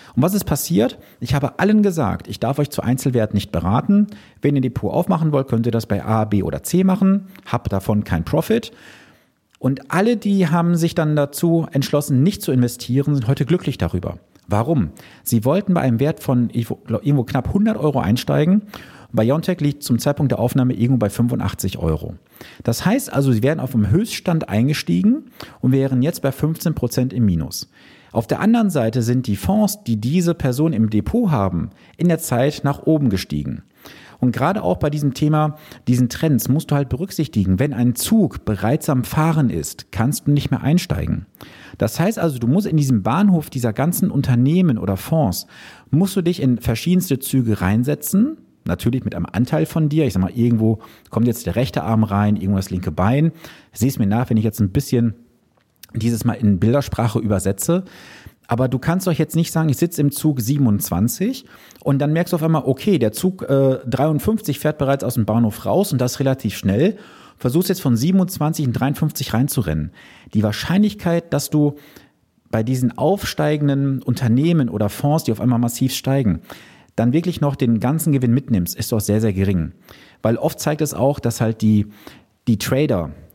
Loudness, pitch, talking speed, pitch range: -19 LUFS, 135 Hz, 185 wpm, 115-155 Hz